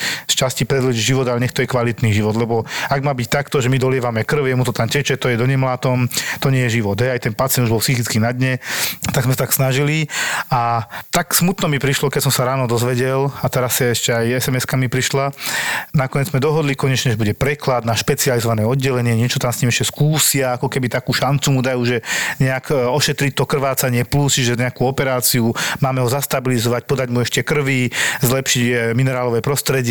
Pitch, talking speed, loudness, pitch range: 130 Hz, 210 wpm, -17 LUFS, 120-140 Hz